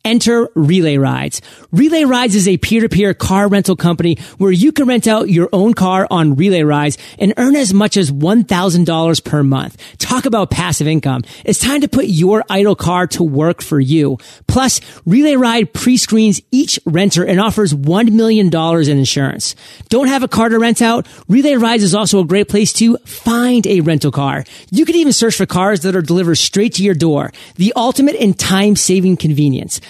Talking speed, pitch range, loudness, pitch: 190 wpm, 165-230 Hz, -12 LUFS, 195 Hz